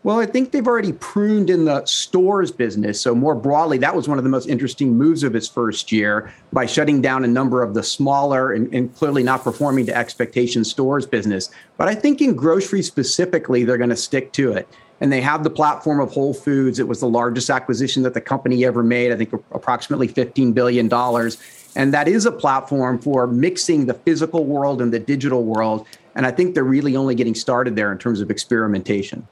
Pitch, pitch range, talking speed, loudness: 130 Hz, 120-145 Hz, 215 wpm, -18 LUFS